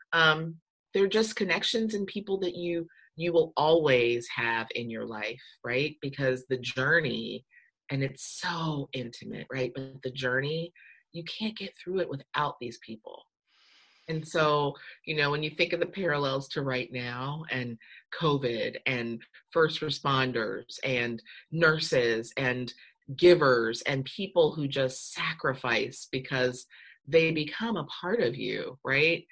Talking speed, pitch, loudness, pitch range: 145 wpm, 145 Hz, -29 LUFS, 130-165 Hz